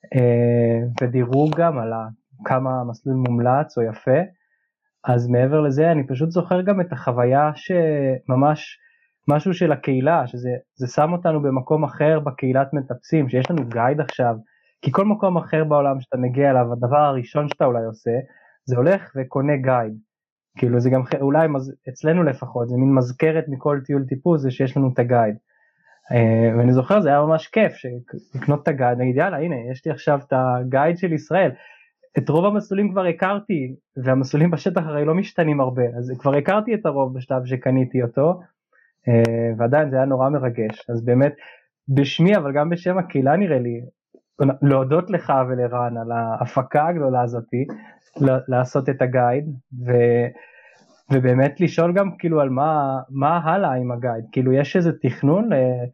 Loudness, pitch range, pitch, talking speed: -20 LUFS, 125-160 Hz, 135 Hz, 160 wpm